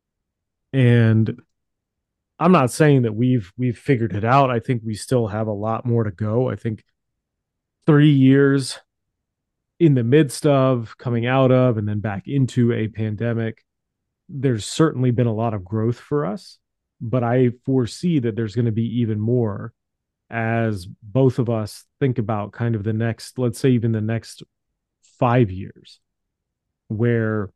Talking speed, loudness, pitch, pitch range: 160 wpm, -20 LUFS, 120 Hz, 110-130 Hz